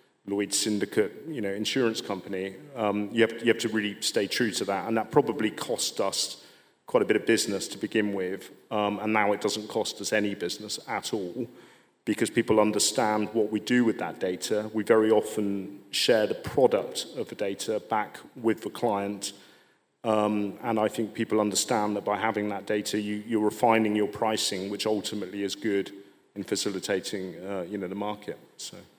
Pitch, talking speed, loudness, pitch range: 105 Hz, 190 wpm, -28 LUFS, 100-110 Hz